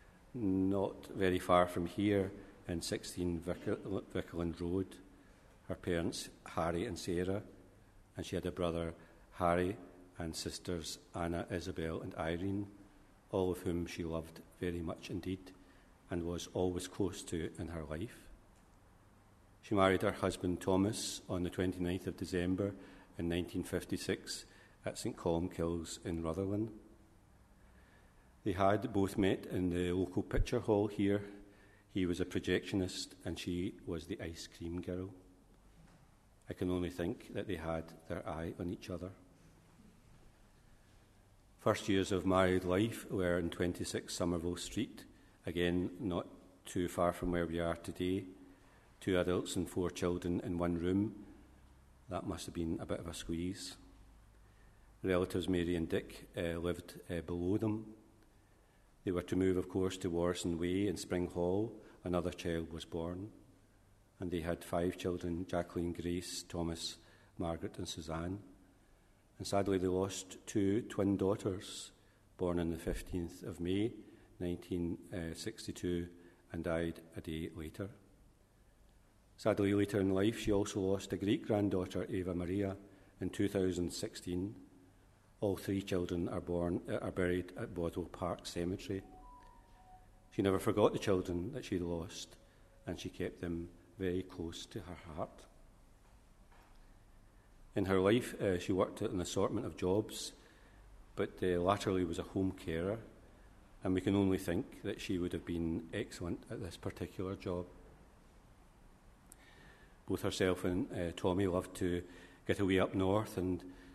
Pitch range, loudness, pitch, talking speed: 85-100 Hz, -38 LUFS, 95 Hz, 145 wpm